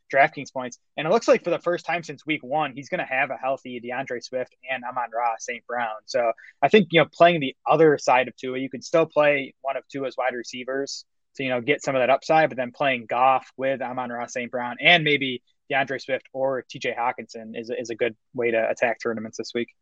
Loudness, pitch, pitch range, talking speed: -24 LUFS, 135 Hz, 125-150 Hz, 240 wpm